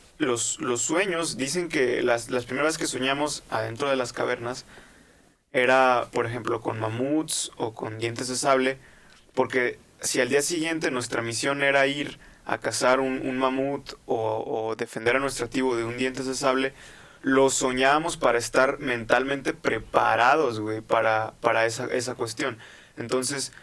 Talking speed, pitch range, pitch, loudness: 155 wpm, 120-140 Hz, 130 Hz, -25 LUFS